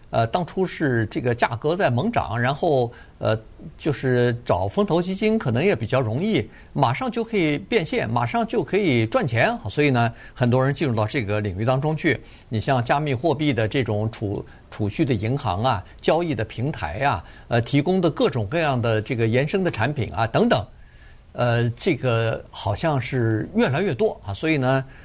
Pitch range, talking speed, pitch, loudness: 115-150 Hz, 270 characters per minute, 130 Hz, -22 LUFS